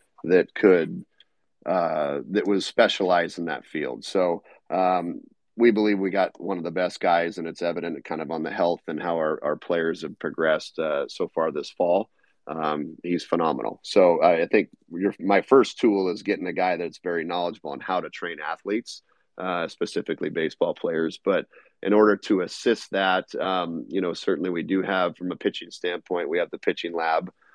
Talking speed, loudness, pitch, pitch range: 195 wpm, -25 LUFS, 90 Hz, 80-95 Hz